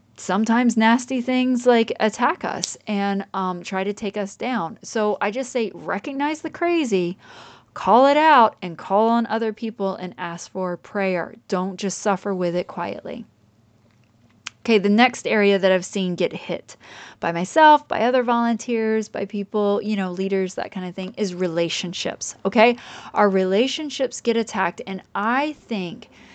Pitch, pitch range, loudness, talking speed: 205 Hz, 185-235 Hz, -21 LUFS, 160 wpm